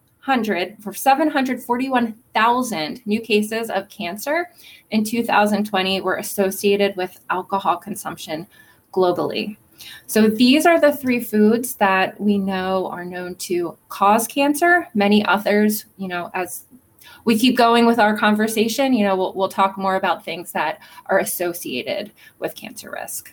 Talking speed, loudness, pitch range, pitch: 135 wpm, -19 LUFS, 190-235 Hz, 210 Hz